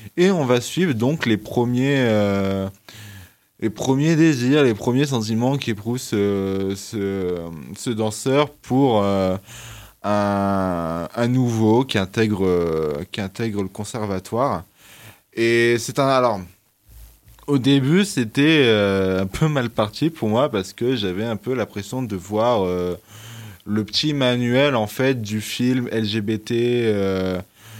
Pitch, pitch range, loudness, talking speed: 110 Hz, 100-125 Hz, -20 LUFS, 140 wpm